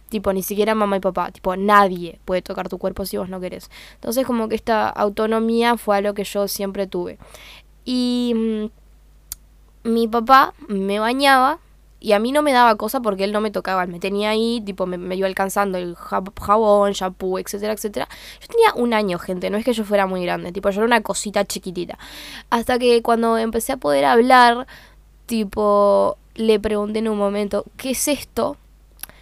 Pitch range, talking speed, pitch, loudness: 195-230 Hz, 190 wpm, 210 Hz, -19 LUFS